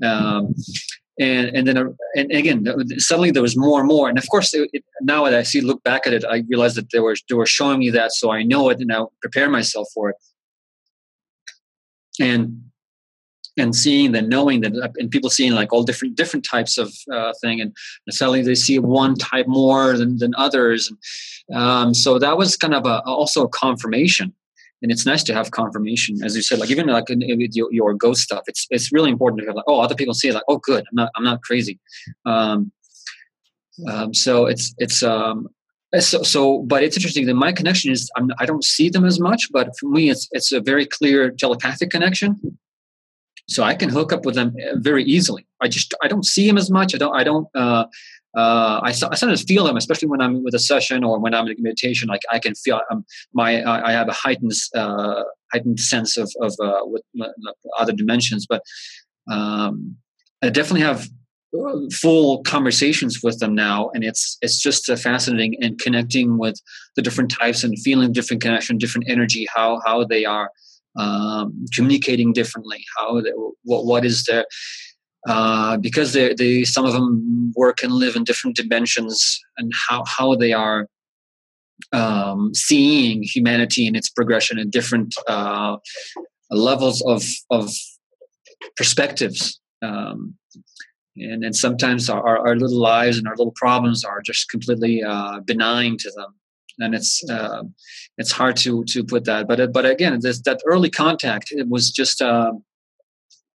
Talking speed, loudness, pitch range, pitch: 190 wpm, -18 LUFS, 115-140 Hz, 120 Hz